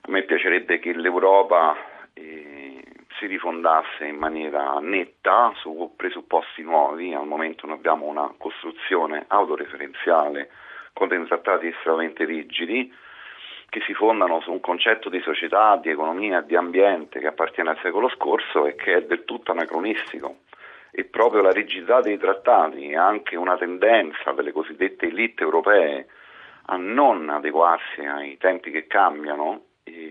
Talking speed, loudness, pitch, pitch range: 140 wpm, -22 LUFS, 80 Hz, 75-90 Hz